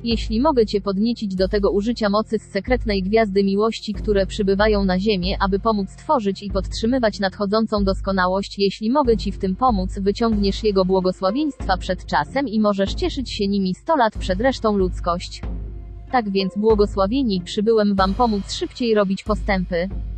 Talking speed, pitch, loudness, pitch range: 160 wpm, 205 Hz, -20 LUFS, 195-225 Hz